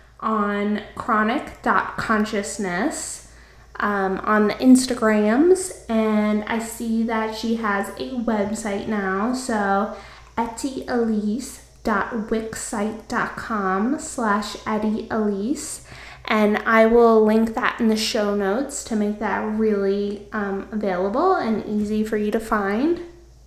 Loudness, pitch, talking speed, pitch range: -22 LUFS, 220 Hz, 100 wpm, 210-230 Hz